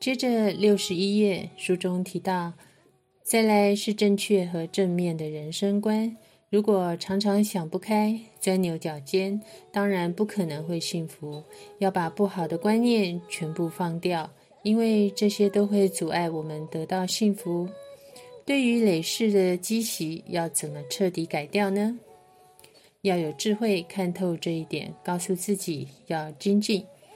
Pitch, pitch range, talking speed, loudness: 190 Hz, 170-210 Hz, 215 characters per minute, -26 LUFS